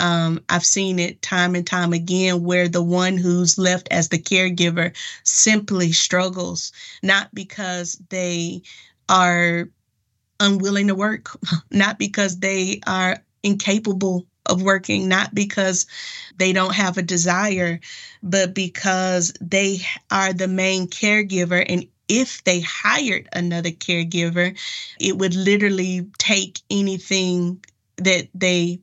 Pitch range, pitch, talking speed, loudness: 175-195 Hz, 185 Hz, 125 wpm, -19 LUFS